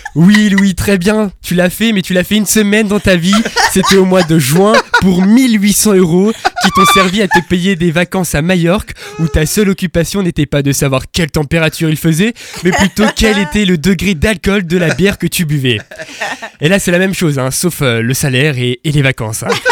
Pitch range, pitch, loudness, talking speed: 160-205 Hz, 185 Hz, -11 LUFS, 225 wpm